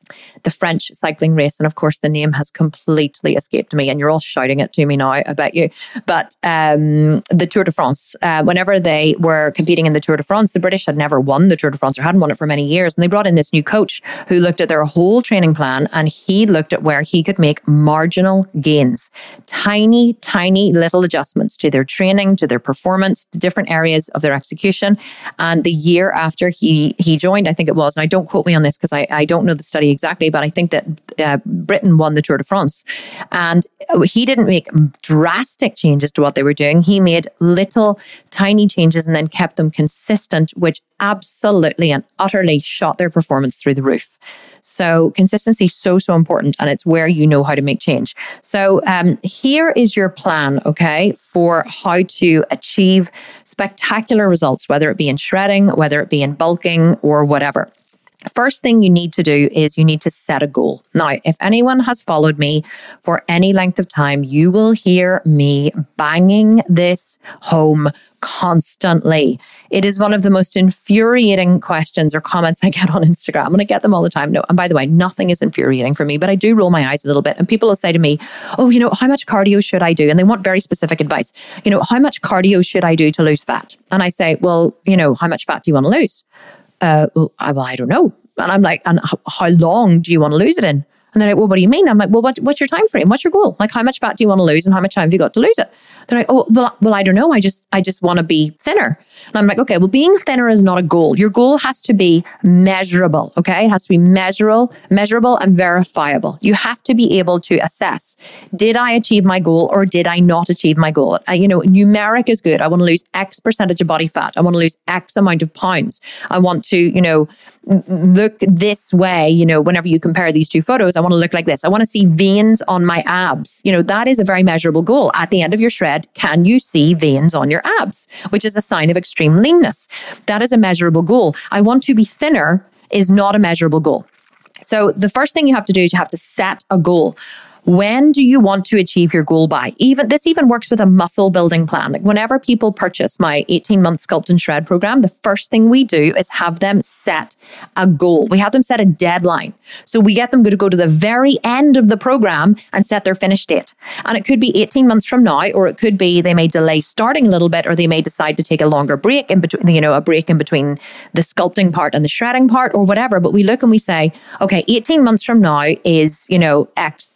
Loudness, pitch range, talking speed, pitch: -13 LUFS, 160-205 Hz, 245 wpm, 180 Hz